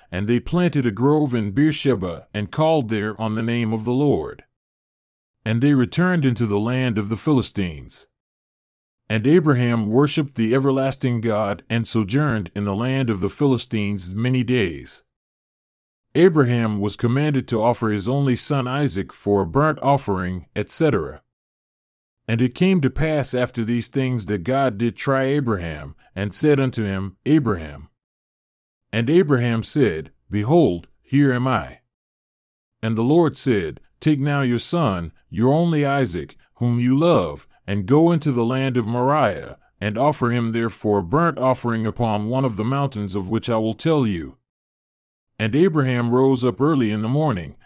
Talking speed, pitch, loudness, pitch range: 160 wpm, 120 Hz, -20 LUFS, 110-140 Hz